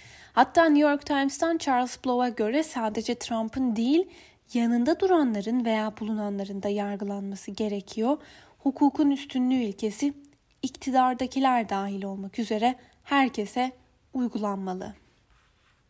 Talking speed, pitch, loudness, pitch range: 100 wpm, 245 Hz, -27 LUFS, 215-275 Hz